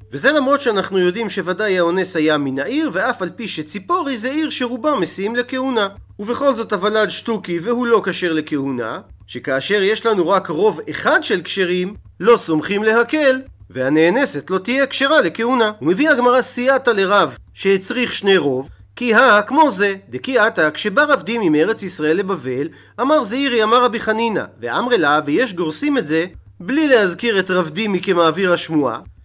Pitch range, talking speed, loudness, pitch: 170-250 Hz, 160 wpm, -17 LUFS, 205 Hz